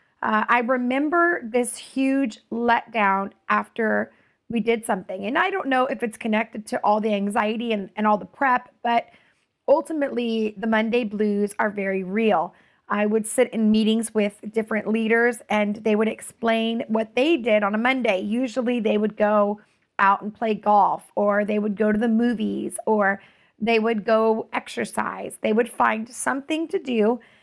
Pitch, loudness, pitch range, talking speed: 225 Hz, -23 LUFS, 210-240 Hz, 170 wpm